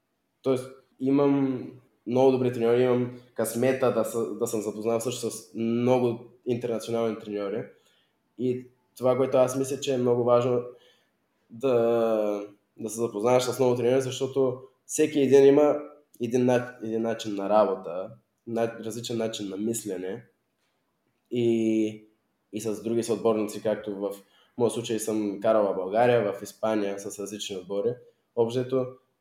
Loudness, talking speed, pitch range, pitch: -26 LUFS, 135 wpm, 110-130 Hz, 120 Hz